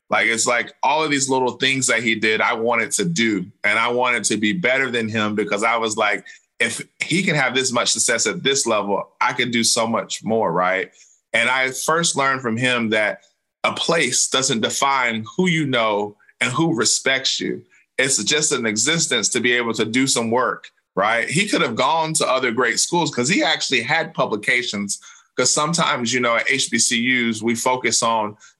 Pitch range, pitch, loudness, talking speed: 115-135 Hz, 120 Hz, -19 LUFS, 200 wpm